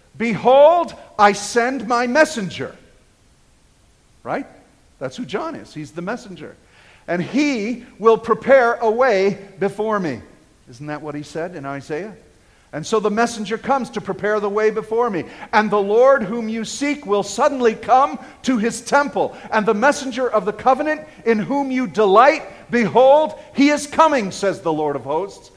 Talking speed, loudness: 165 wpm, -18 LUFS